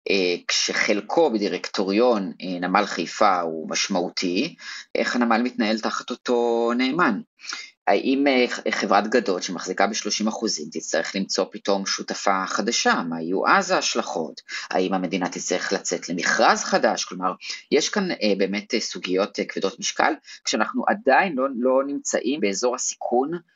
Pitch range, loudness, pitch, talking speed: 95-125 Hz, -23 LUFS, 105 Hz, 130 wpm